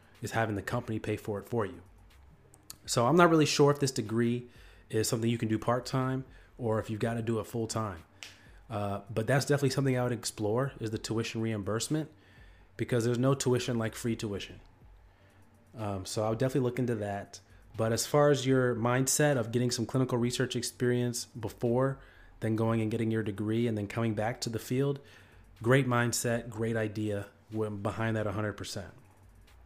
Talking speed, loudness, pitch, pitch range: 190 wpm, -31 LUFS, 115 Hz, 105-125 Hz